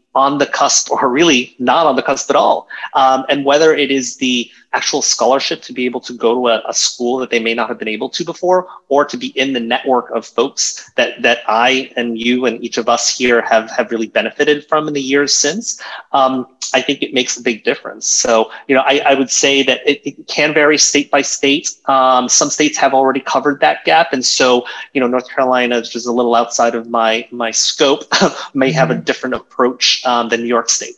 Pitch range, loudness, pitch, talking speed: 120-140 Hz, -14 LUFS, 130 Hz, 235 wpm